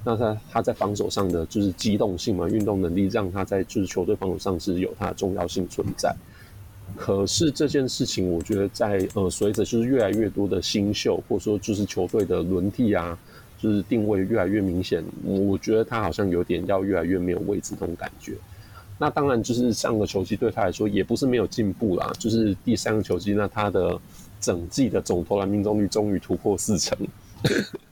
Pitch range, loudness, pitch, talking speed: 95-110 Hz, -24 LUFS, 100 Hz, 310 characters per minute